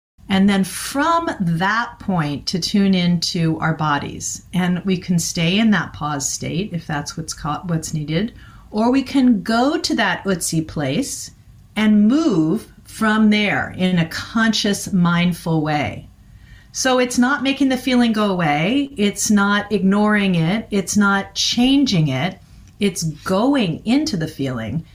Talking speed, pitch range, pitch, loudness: 150 wpm, 165-225 Hz, 195 Hz, -18 LUFS